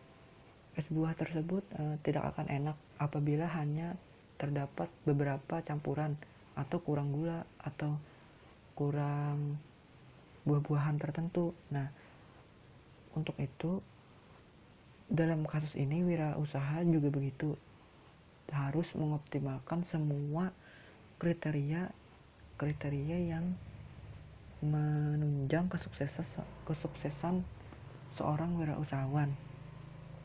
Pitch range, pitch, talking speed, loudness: 140-160 Hz, 150 Hz, 75 wpm, -37 LUFS